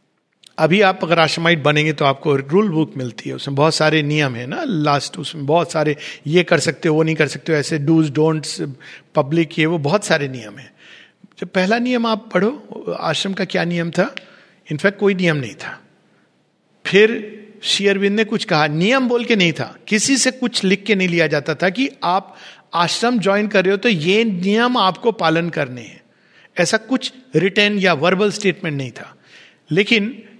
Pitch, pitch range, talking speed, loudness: 175 Hz, 155-210 Hz, 190 wpm, -17 LUFS